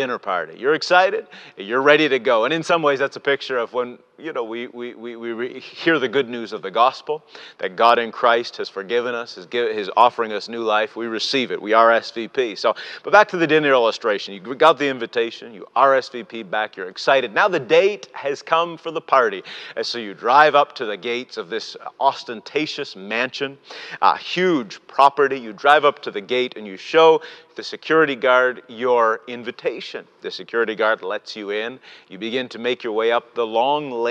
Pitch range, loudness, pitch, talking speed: 115-165 Hz, -19 LUFS, 135 Hz, 210 wpm